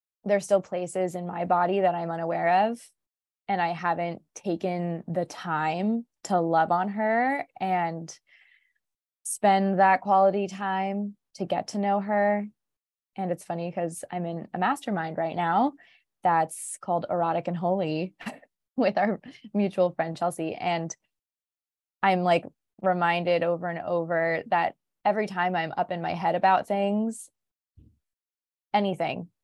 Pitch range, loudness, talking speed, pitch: 170-200 Hz, -27 LUFS, 140 wpm, 180 Hz